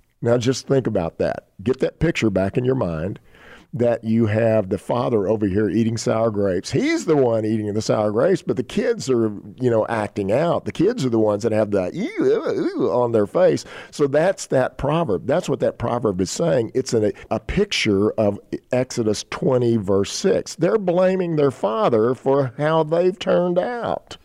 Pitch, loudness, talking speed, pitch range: 120 Hz, -20 LUFS, 195 wpm, 110-160 Hz